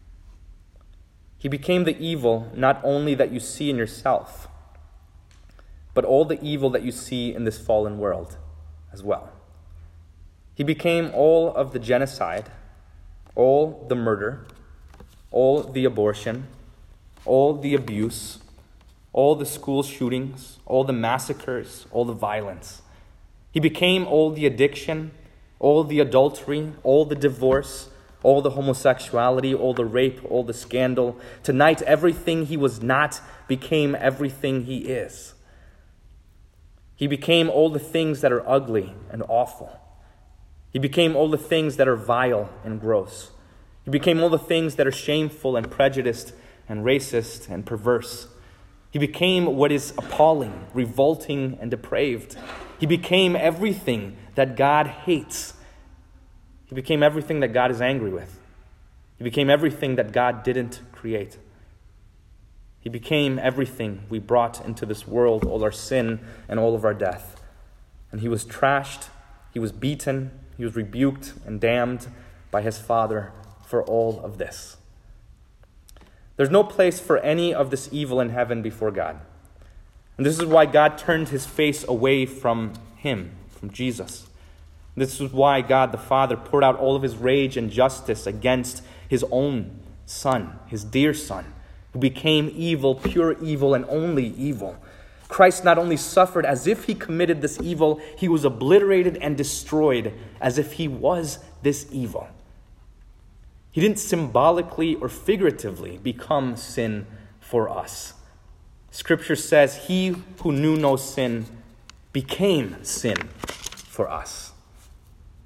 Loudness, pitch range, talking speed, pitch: -22 LUFS, 105-145 Hz, 140 wpm, 125 Hz